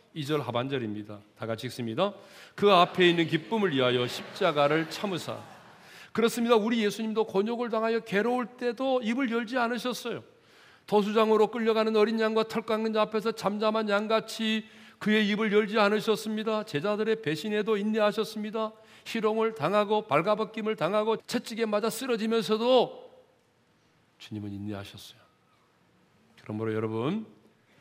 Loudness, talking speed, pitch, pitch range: -28 LUFS, 340 characters per minute, 215 Hz, 175-225 Hz